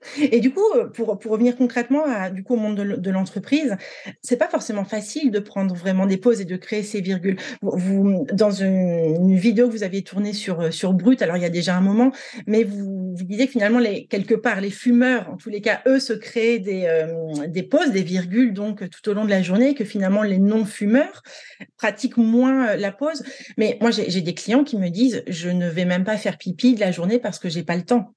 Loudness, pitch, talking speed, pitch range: -21 LUFS, 210 Hz, 245 wpm, 190-245 Hz